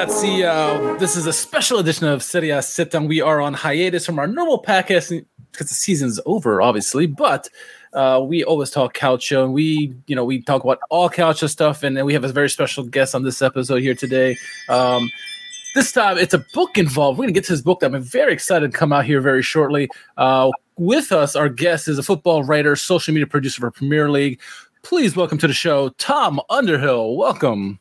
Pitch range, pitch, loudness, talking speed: 135-175 Hz, 150 Hz, -18 LUFS, 220 wpm